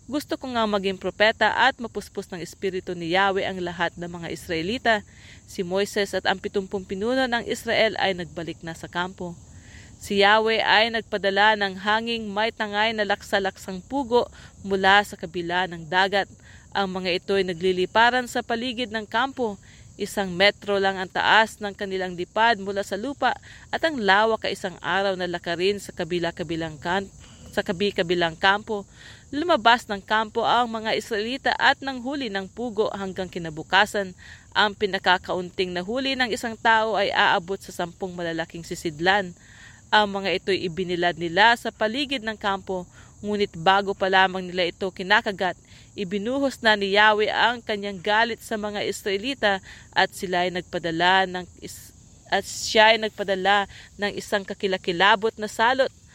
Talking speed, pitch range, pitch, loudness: 155 wpm, 185-220 Hz, 200 Hz, -23 LUFS